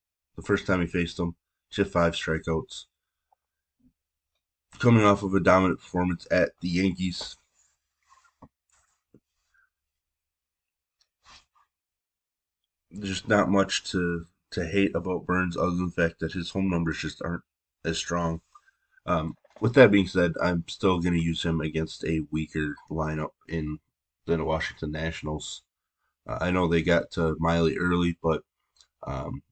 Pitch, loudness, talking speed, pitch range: 85 Hz, -26 LUFS, 145 wpm, 80-90 Hz